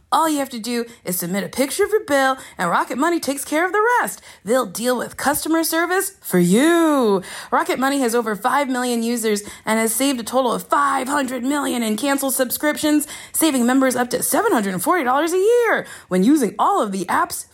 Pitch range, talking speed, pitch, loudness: 240-320 Hz, 200 wpm, 270 Hz, -19 LUFS